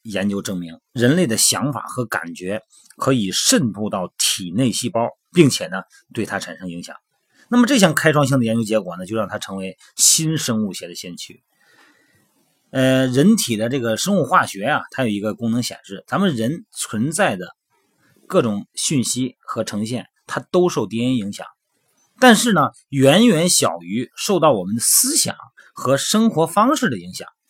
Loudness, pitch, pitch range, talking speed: -18 LUFS, 125 Hz, 110-165 Hz, 255 characters per minute